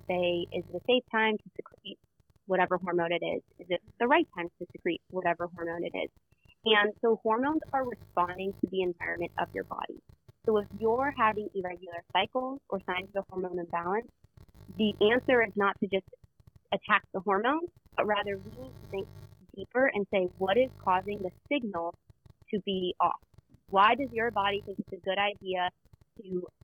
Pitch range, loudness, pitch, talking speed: 180-220 Hz, -30 LUFS, 195 Hz, 180 wpm